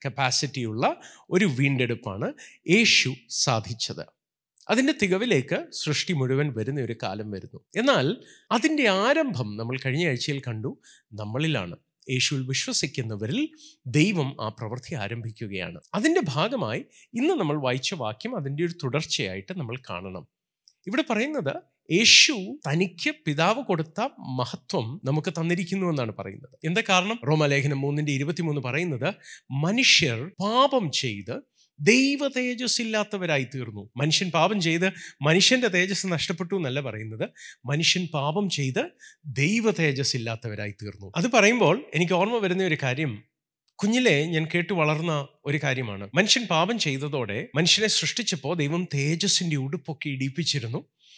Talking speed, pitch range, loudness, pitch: 115 wpm, 130-185 Hz, -24 LUFS, 155 Hz